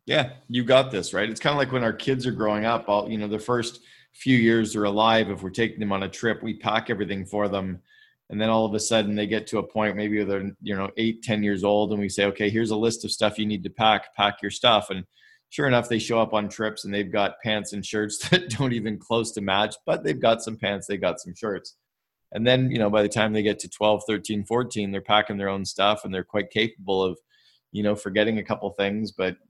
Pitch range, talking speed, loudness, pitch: 100-115 Hz, 265 wpm, -24 LUFS, 105 Hz